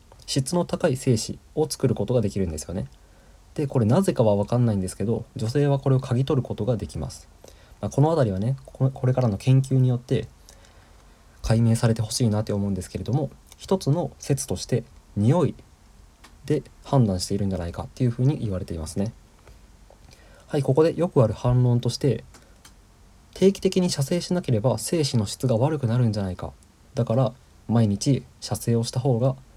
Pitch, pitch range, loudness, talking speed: 120 Hz, 100-135 Hz, -24 LUFS, 370 characters per minute